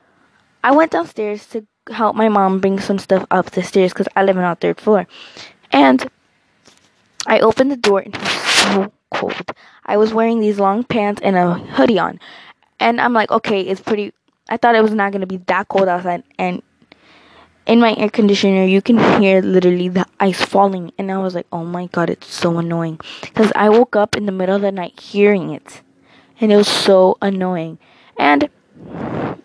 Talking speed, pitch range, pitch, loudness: 195 wpm, 185-215 Hz, 200 Hz, -15 LUFS